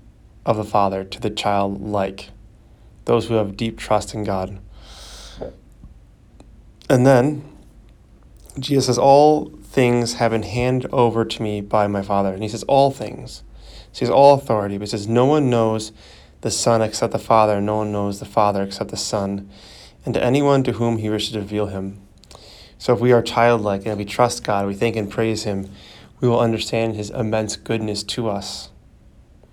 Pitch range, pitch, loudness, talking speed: 100-115 Hz, 110 Hz, -19 LUFS, 185 wpm